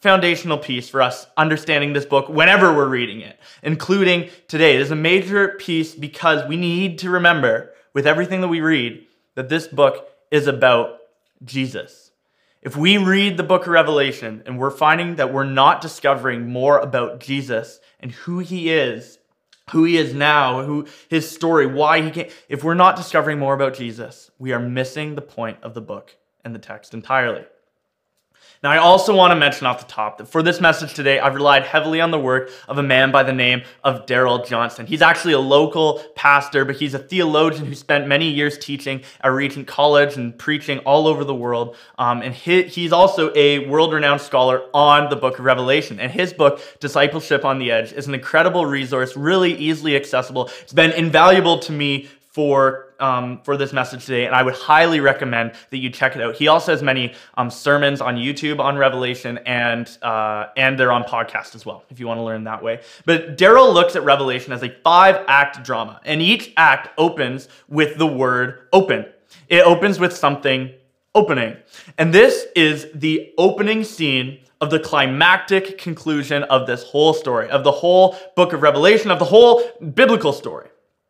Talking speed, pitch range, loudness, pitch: 190 wpm, 130-165 Hz, -16 LUFS, 145 Hz